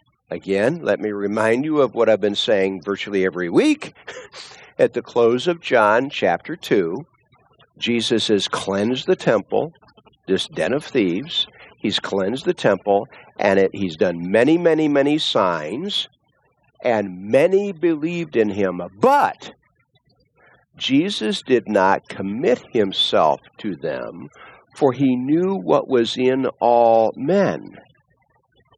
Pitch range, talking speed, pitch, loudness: 100-155 Hz, 130 wpm, 120 Hz, -19 LUFS